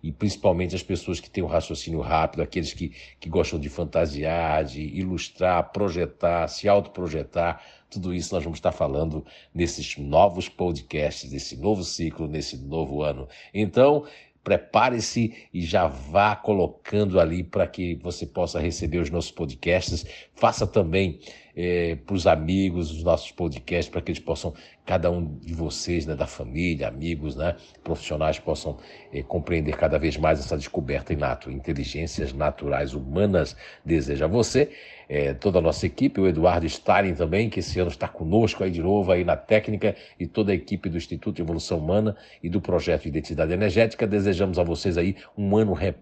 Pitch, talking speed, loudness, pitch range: 85 Hz, 170 wpm, -25 LUFS, 80-95 Hz